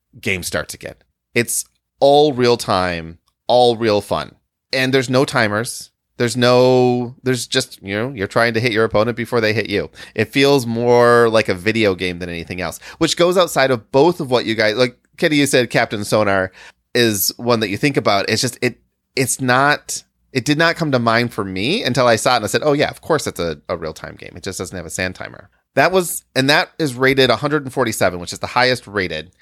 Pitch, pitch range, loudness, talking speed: 120 Hz, 100-130 Hz, -17 LUFS, 225 wpm